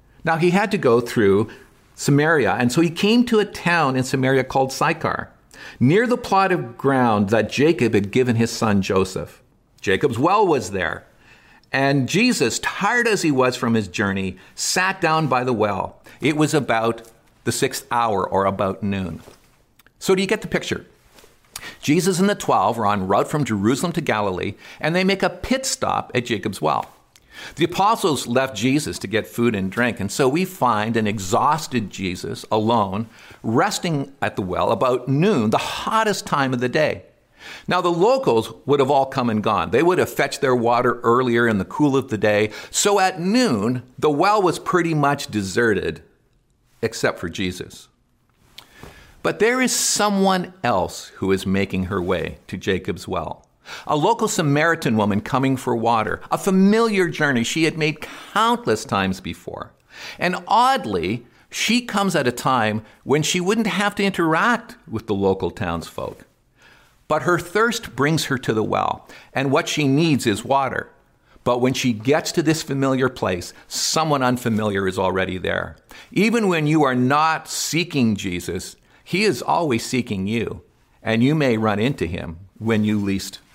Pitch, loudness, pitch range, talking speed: 130 Hz, -20 LUFS, 110-175 Hz, 170 wpm